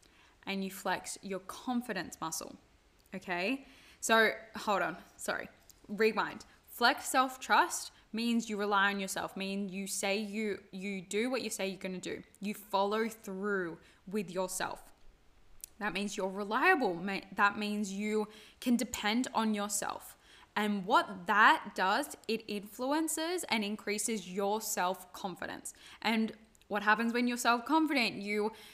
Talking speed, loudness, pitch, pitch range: 135 wpm, -33 LUFS, 210 Hz, 195-225 Hz